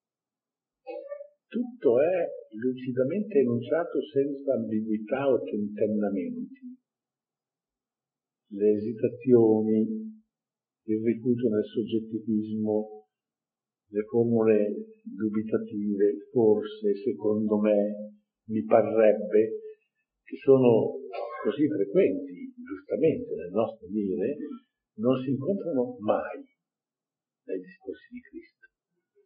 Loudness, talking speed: -27 LUFS, 80 wpm